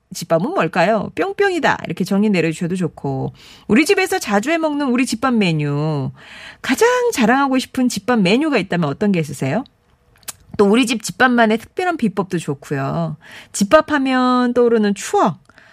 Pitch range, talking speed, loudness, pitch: 165-255 Hz, 335 characters per minute, -17 LUFS, 215 Hz